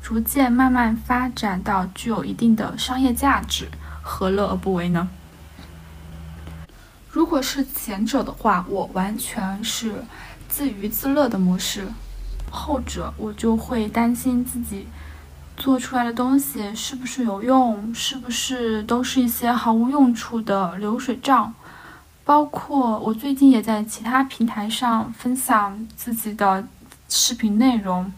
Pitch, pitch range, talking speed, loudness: 225 Hz, 195-255 Hz, 205 characters per minute, -21 LUFS